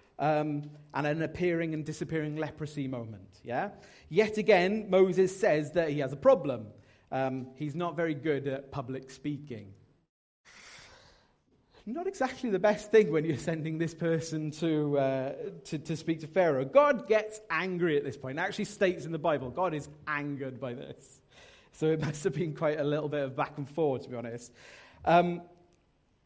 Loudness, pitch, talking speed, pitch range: -30 LUFS, 155 Hz, 175 wpm, 140-175 Hz